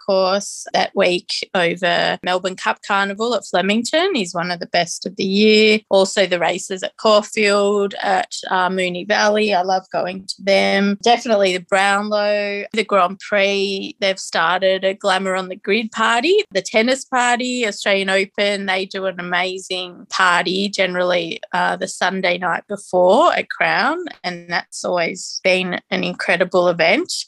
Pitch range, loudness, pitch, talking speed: 185-210 Hz, -18 LUFS, 195 Hz, 155 wpm